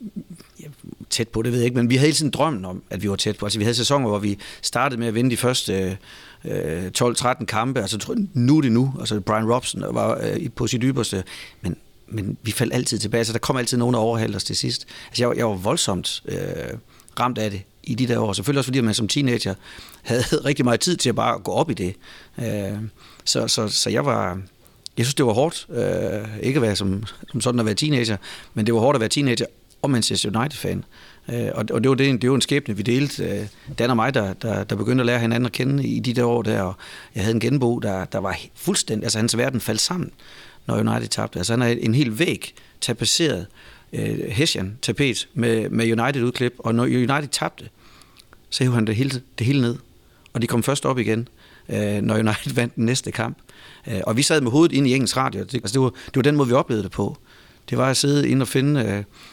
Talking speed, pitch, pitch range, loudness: 240 wpm, 120 Hz, 110-130 Hz, -22 LUFS